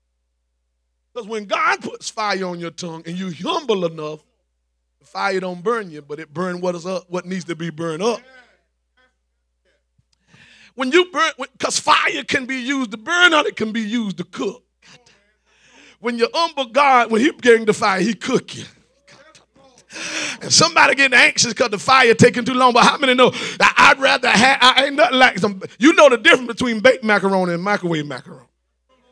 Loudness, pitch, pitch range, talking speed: -16 LUFS, 215 Hz, 170-255 Hz, 190 wpm